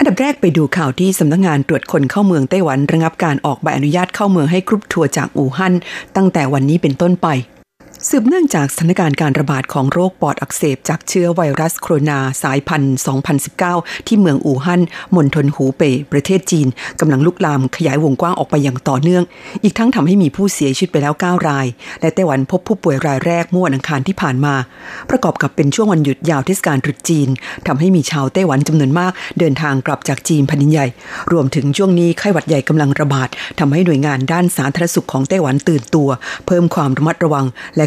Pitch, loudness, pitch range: 155 Hz, -14 LUFS, 140-180 Hz